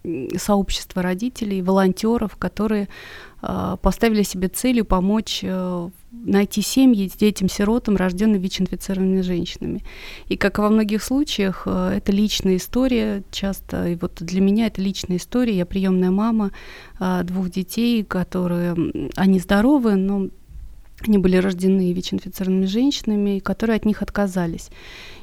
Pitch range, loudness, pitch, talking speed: 185-215 Hz, -21 LUFS, 195 Hz, 130 wpm